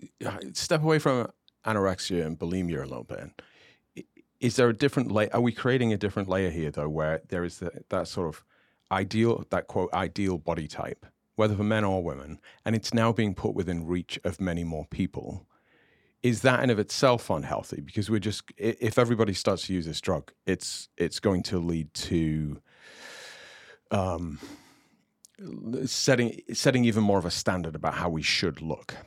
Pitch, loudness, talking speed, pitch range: 100 Hz, -28 LUFS, 175 wpm, 85-115 Hz